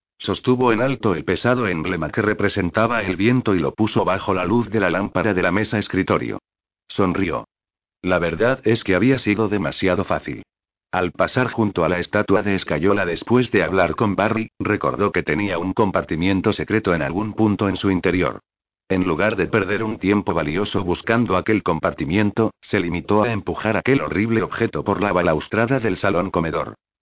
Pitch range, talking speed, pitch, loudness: 90-110 Hz, 180 wpm, 100 Hz, -20 LUFS